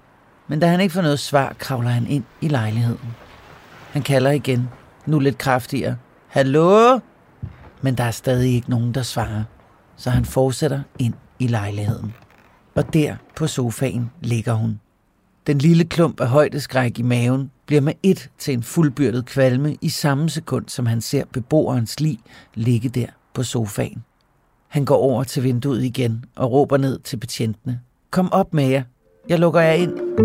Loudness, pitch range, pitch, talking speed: -20 LUFS, 120-145 Hz, 130 Hz, 165 wpm